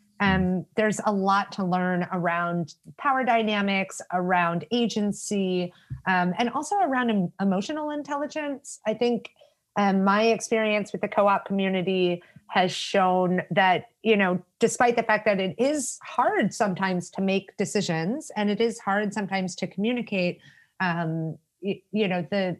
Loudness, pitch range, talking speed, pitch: -25 LUFS, 185-225 Hz, 145 wpm, 200 Hz